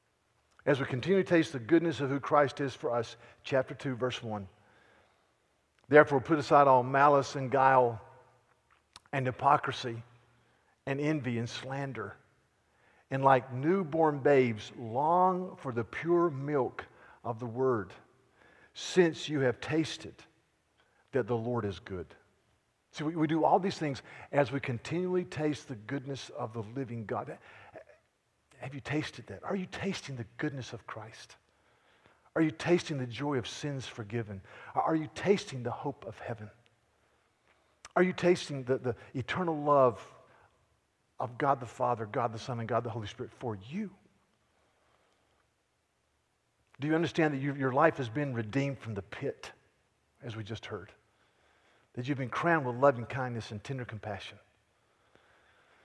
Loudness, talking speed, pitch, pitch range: -31 LUFS, 155 wpm, 130 Hz, 120-150 Hz